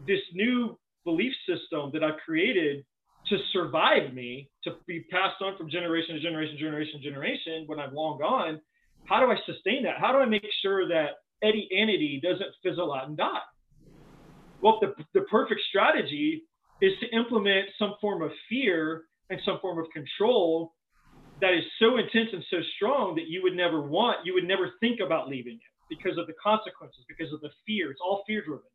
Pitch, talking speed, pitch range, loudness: 180 Hz, 190 wpm, 155-210 Hz, -28 LUFS